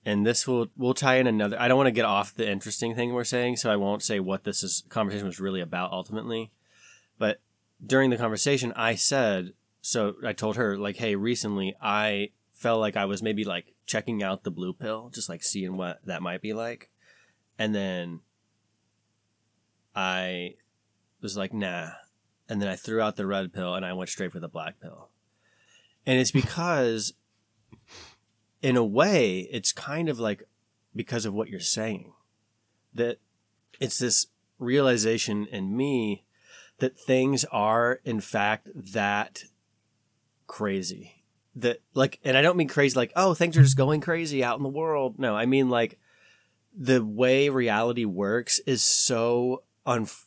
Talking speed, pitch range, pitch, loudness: 170 wpm, 105-125 Hz, 110 Hz, -26 LUFS